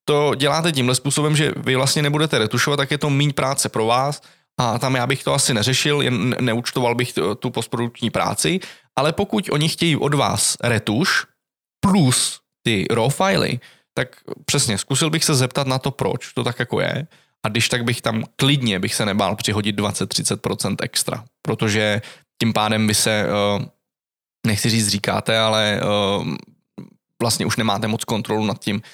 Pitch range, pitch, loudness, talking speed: 110-145 Hz, 125 Hz, -19 LUFS, 170 wpm